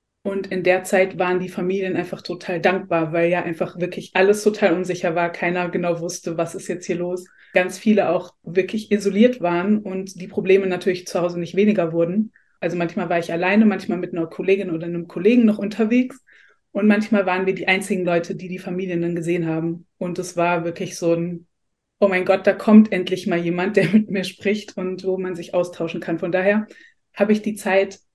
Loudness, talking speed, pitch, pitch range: -21 LUFS, 210 wpm, 185 Hz, 175-200 Hz